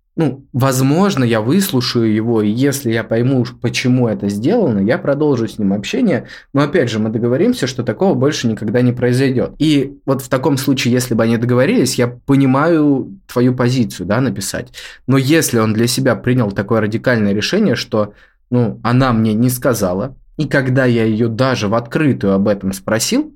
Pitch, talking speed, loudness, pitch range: 125 Hz, 175 wpm, -15 LUFS, 115-135 Hz